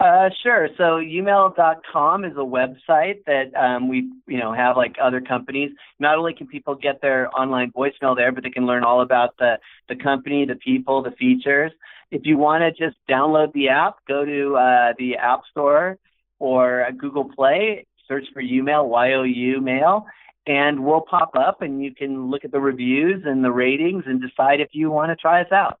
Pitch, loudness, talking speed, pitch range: 140 Hz, -19 LUFS, 195 wpm, 130-155 Hz